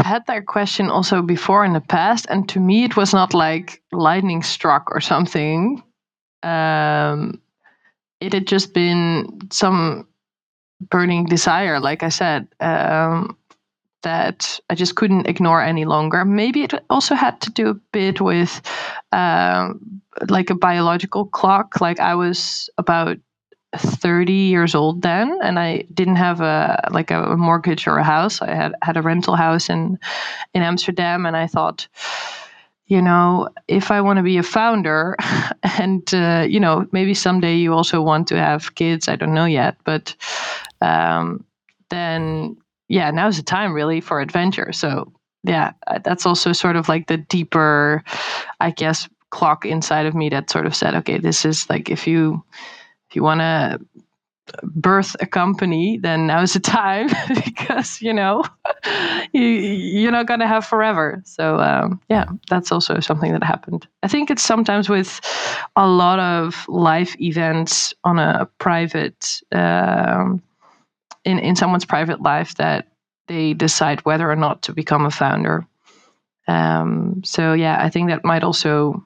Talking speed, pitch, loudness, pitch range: 160 wpm, 175 Hz, -18 LUFS, 160-195 Hz